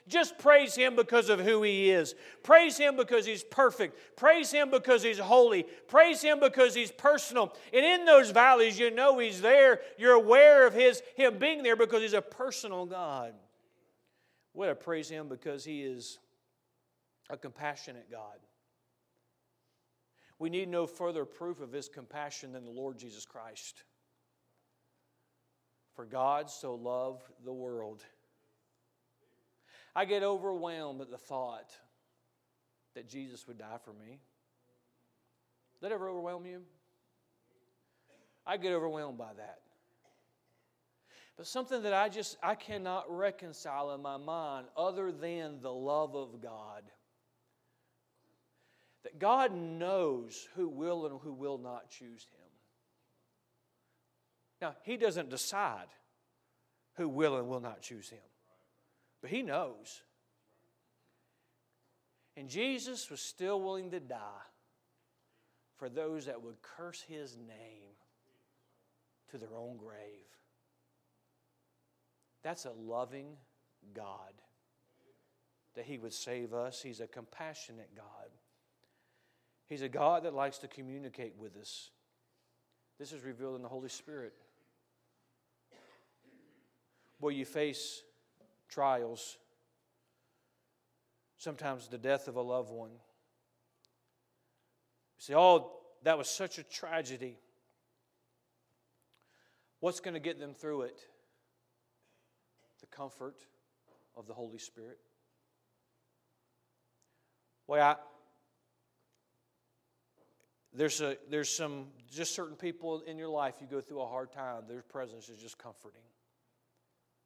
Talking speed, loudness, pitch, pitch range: 120 wpm, -29 LUFS, 140 Hz, 120-180 Hz